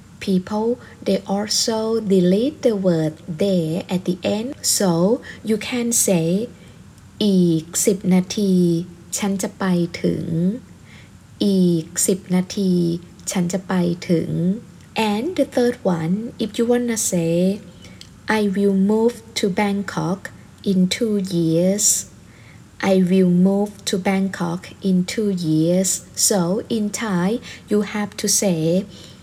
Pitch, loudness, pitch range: 195 Hz, -20 LUFS, 175-215 Hz